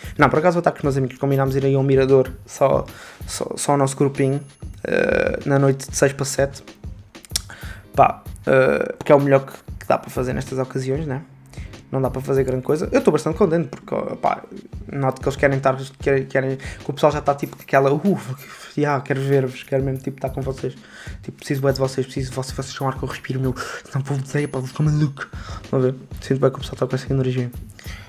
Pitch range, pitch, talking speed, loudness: 130-140 Hz, 135 Hz, 235 wpm, -21 LUFS